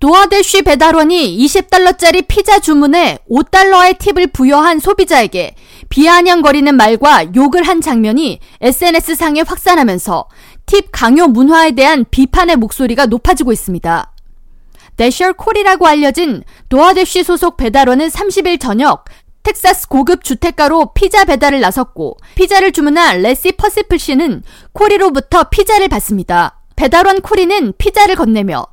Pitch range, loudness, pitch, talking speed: 270-370 Hz, -9 LUFS, 325 Hz, 320 characters per minute